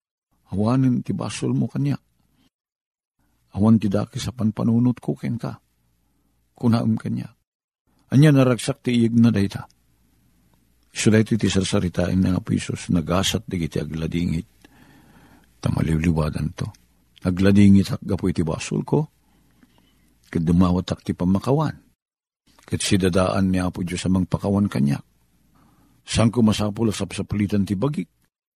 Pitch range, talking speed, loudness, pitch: 80-110 Hz, 120 wpm, -21 LUFS, 95 Hz